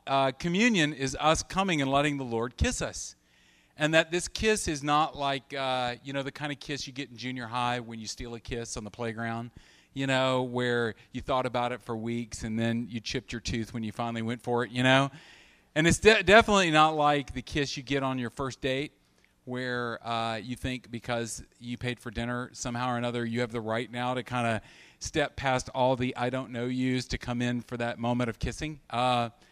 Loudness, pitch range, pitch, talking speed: -29 LUFS, 120-140 Hz, 125 Hz, 230 wpm